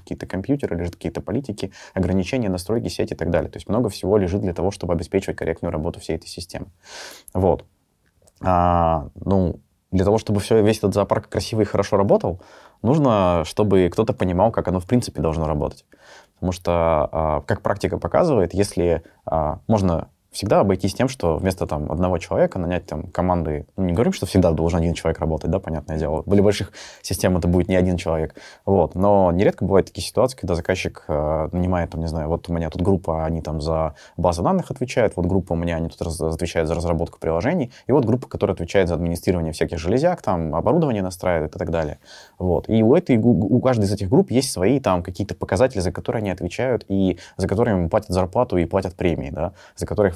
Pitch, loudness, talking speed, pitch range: 90 Hz, -21 LUFS, 200 wpm, 85-100 Hz